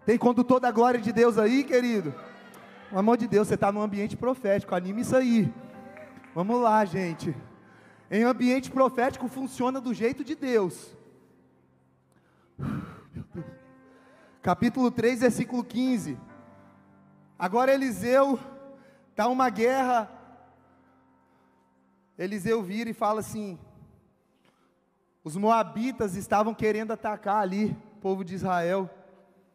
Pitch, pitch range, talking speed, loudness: 215 Hz, 180-245 Hz, 115 wpm, -26 LUFS